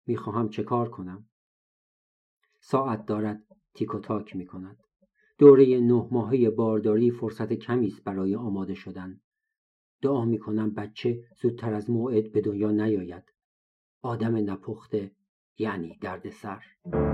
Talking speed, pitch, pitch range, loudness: 125 wpm, 110 Hz, 100-120 Hz, -26 LUFS